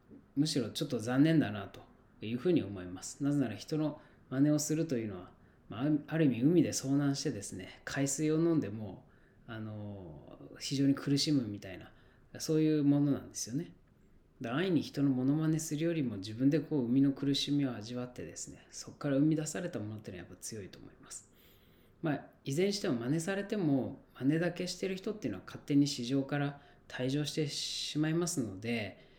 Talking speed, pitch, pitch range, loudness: 380 characters per minute, 140 Hz, 120-150 Hz, -33 LUFS